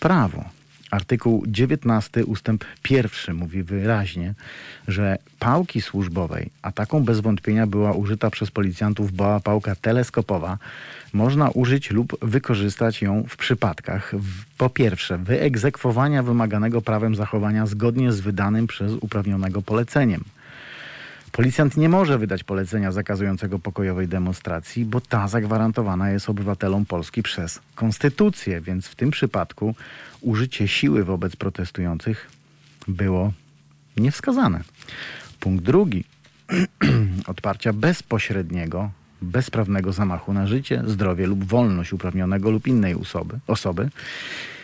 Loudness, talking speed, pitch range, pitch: -22 LUFS, 110 wpm, 100-120 Hz, 110 Hz